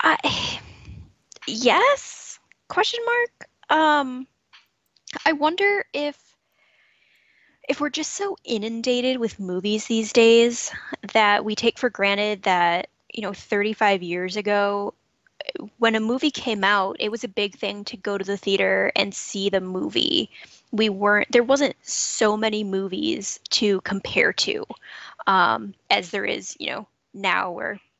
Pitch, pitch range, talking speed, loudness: 220 Hz, 200-260 Hz, 140 wpm, -22 LUFS